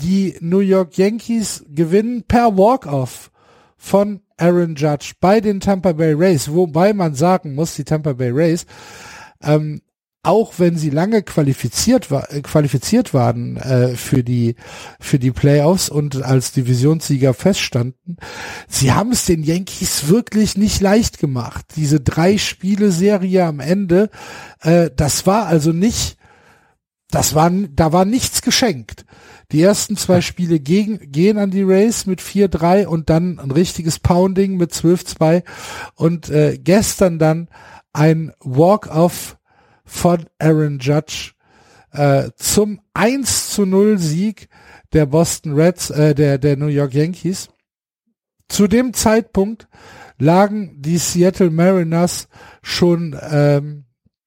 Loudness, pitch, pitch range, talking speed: -16 LUFS, 170 Hz, 150-195 Hz, 130 wpm